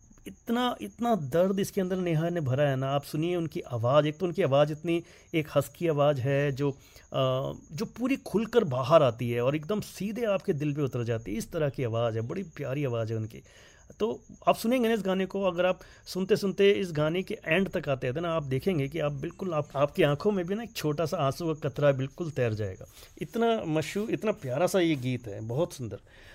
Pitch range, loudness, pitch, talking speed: 135-190 Hz, -29 LUFS, 155 Hz, 225 wpm